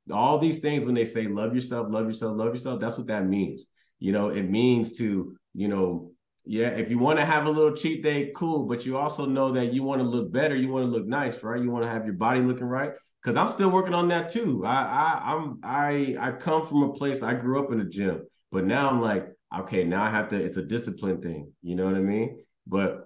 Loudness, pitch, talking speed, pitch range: -27 LUFS, 120 Hz, 260 wpm, 110-140 Hz